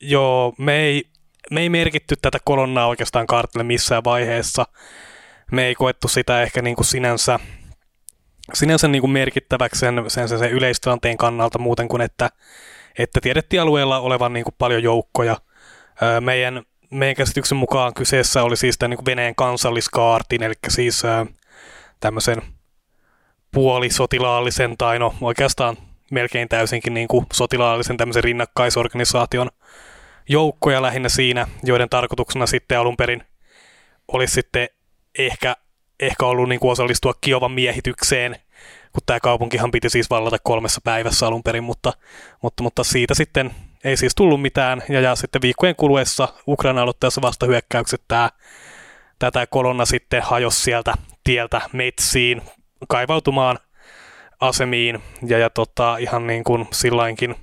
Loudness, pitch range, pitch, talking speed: -19 LUFS, 120-130 Hz, 125 Hz, 135 wpm